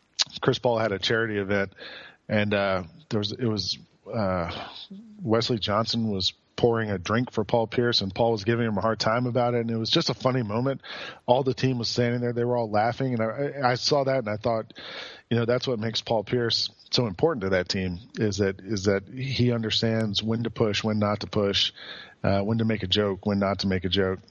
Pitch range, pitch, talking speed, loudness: 105-120 Hz, 115 Hz, 230 wpm, -26 LUFS